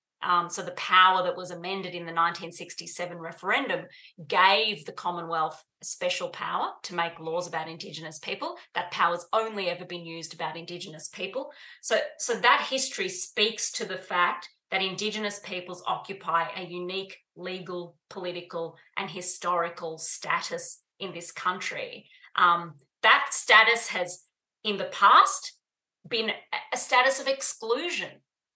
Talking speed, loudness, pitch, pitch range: 140 wpm, -26 LUFS, 180 Hz, 170-220 Hz